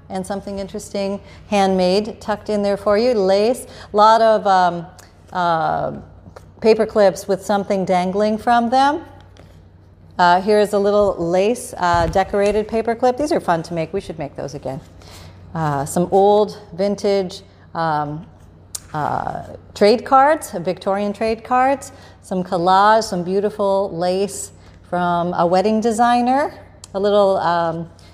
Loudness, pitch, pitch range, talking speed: -18 LUFS, 195 Hz, 175-210 Hz, 140 wpm